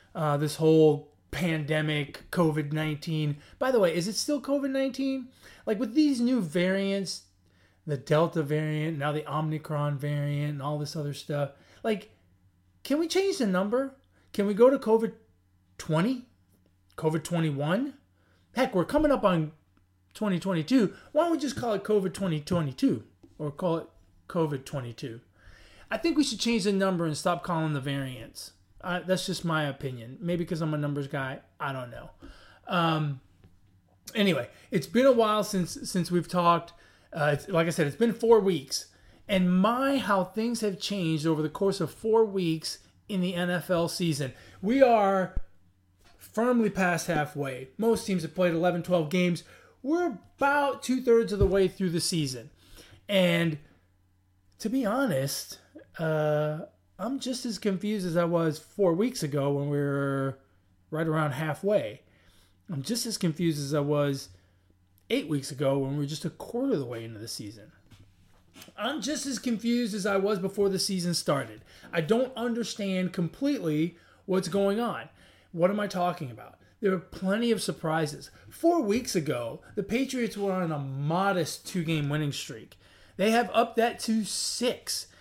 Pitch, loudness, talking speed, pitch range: 170 Hz, -28 LUFS, 165 wpm, 145-210 Hz